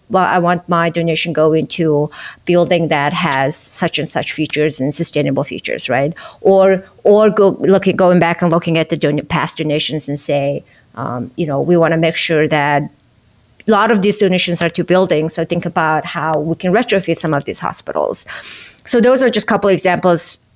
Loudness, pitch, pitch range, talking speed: -14 LUFS, 165 Hz, 150-180 Hz, 200 wpm